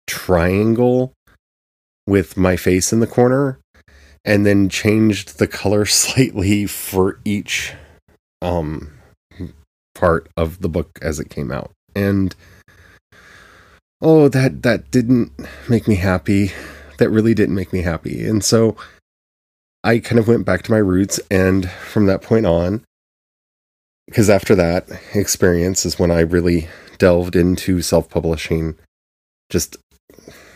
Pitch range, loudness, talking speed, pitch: 80-105 Hz, -17 LUFS, 130 wpm, 90 Hz